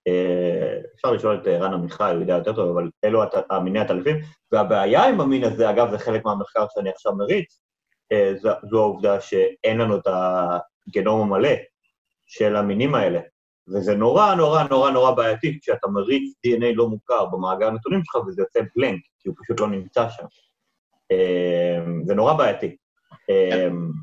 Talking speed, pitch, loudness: 170 wpm, 120 Hz, -21 LUFS